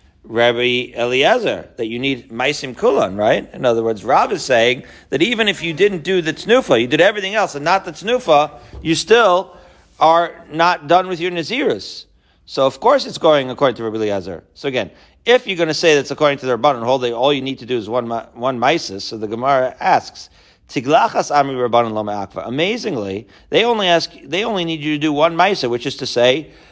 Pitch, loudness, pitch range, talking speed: 140 Hz, -17 LUFS, 120-175 Hz, 210 wpm